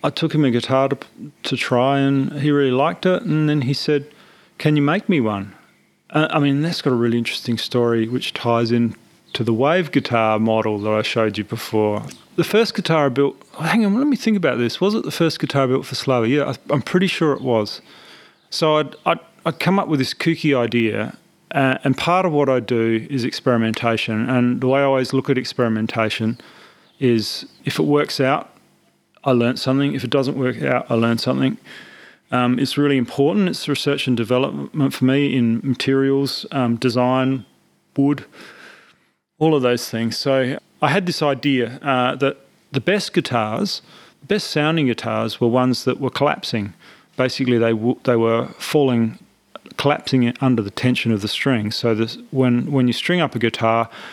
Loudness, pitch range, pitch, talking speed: -19 LUFS, 115-145 Hz, 130 Hz, 195 wpm